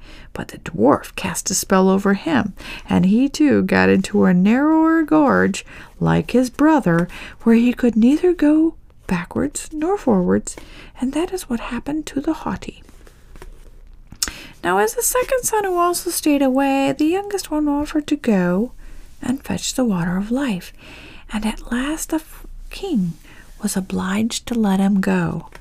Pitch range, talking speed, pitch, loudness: 195-310 Hz, 155 wpm, 255 Hz, -19 LUFS